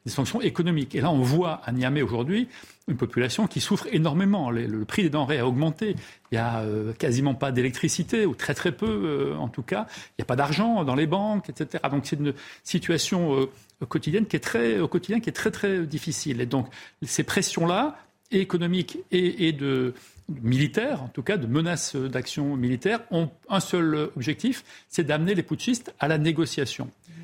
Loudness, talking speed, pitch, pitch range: -26 LUFS, 185 wpm, 155 Hz, 135-180 Hz